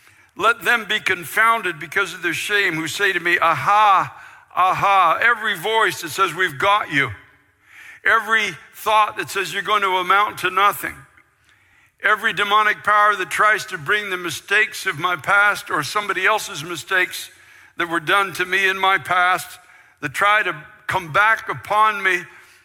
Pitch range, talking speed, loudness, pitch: 180-210 Hz, 165 wpm, -18 LUFS, 195 Hz